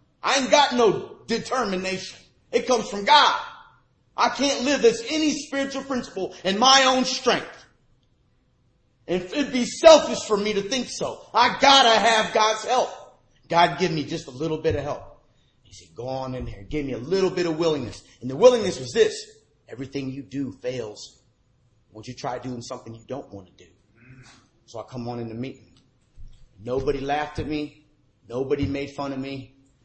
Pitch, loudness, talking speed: 150 Hz, -22 LUFS, 185 wpm